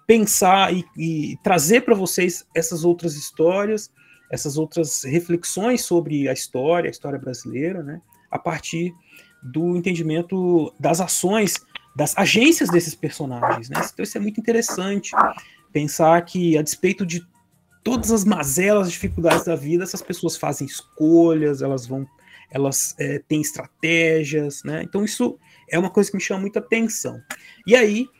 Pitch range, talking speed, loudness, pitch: 155-195 Hz, 150 wpm, -20 LUFS, 170 Hz